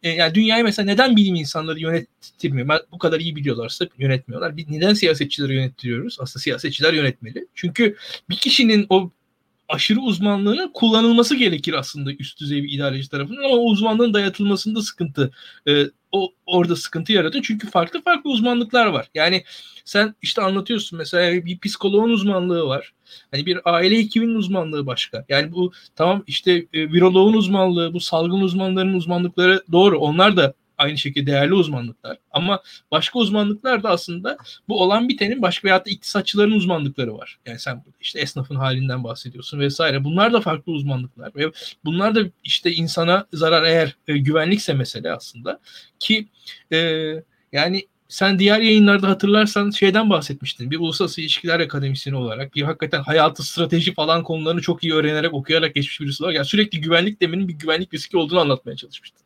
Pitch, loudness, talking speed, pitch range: 175 Hz, -19 LUFS, 155 wpm, 150-200 Hz